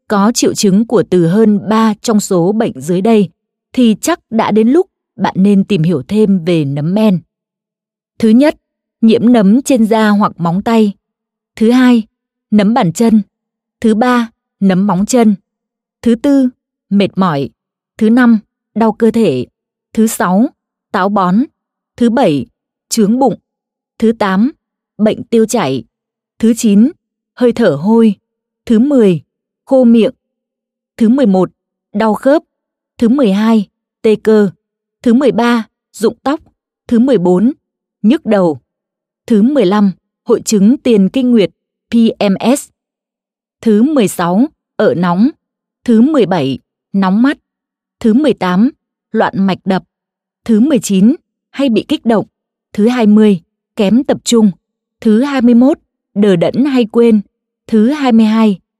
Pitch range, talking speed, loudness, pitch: 205-240 Hz, 135 wpm, -11 LUFS, 225 Hz